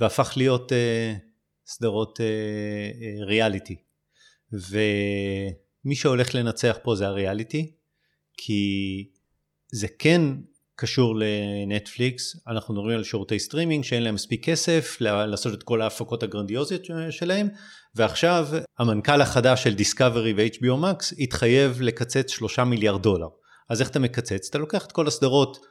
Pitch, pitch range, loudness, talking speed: 115 Hz, 105-135 Hz, -24 LUFS, 125 wpm